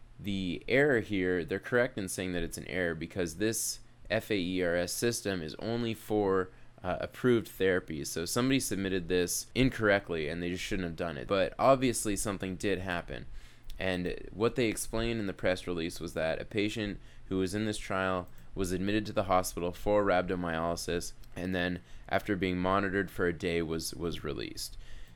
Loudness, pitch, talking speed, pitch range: -32 LUFS, 95 Hz, 175 wpm, 90-105 Hz